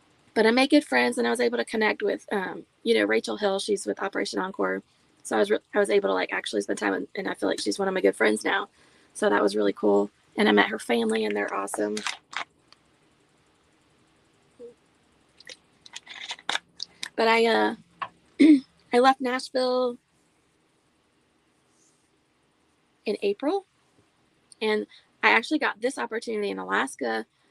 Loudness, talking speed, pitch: -25 LUFS, 160 wpm, 195 Hz